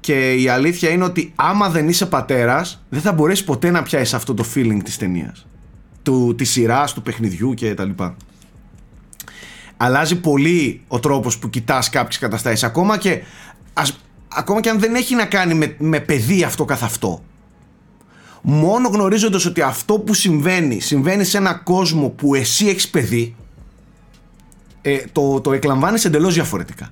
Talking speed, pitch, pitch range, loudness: 155 wpm, 145 Hz, 125-180 Hz, -17 LUFS